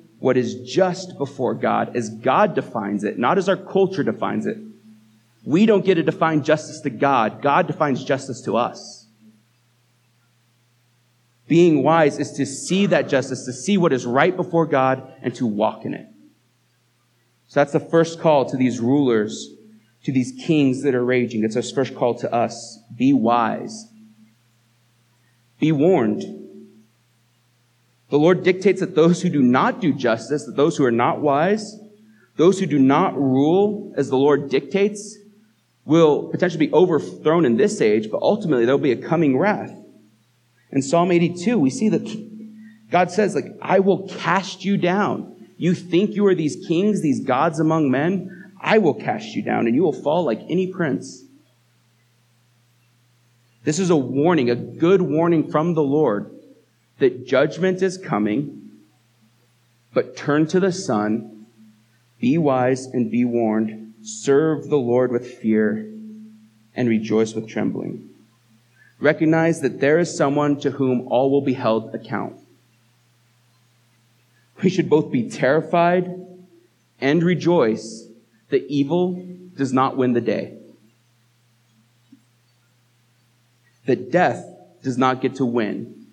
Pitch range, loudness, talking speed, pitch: 120-170 Hz, -20 LUFS, 150 wpm, 130 Hz